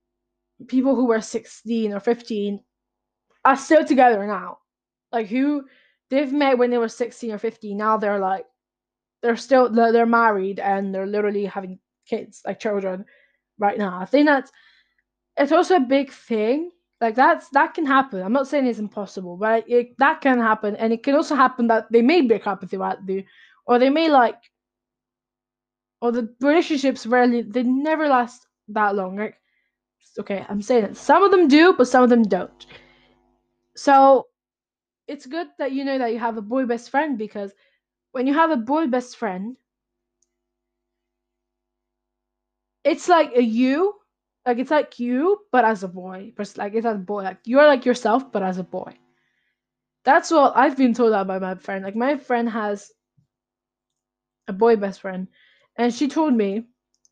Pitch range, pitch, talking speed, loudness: 205-270 Hz, 235 Hz, 175 wpm, -20 LUFS